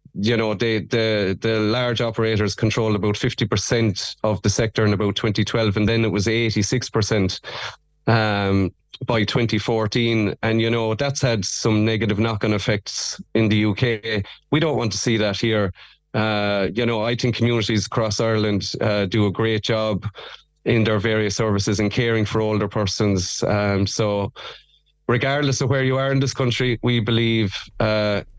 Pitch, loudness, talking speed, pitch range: 110 Hz, -21 LUFS, 175 wpm, 105-120 Hz